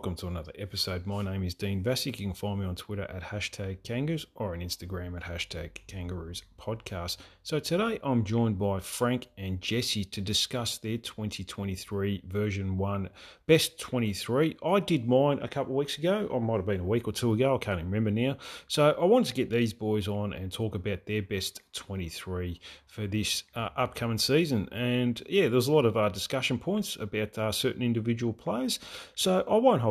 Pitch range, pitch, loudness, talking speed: 95-125 Hz, 105 Hz, -30 LUFS, 205 wpm